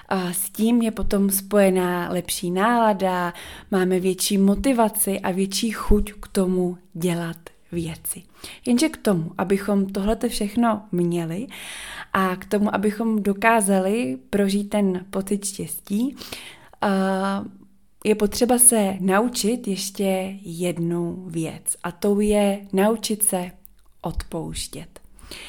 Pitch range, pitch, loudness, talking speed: 185-215 Hz, 195 Hz, -22 LUFS, 110 wpm